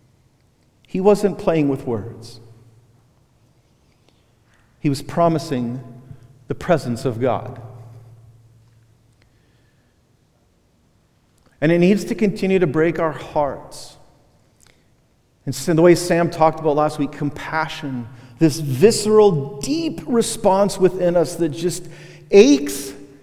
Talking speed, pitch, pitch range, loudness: 100 wpm, 140 Hz, 120-170 Hz, -18 LUFS